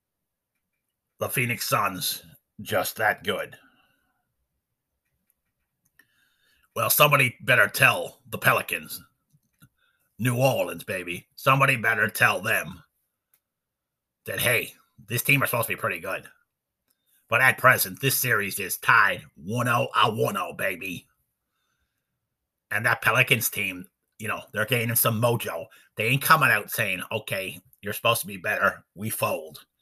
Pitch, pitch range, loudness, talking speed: 120 Hz, 110-130 Hz, -23 LUFS, 125 wpm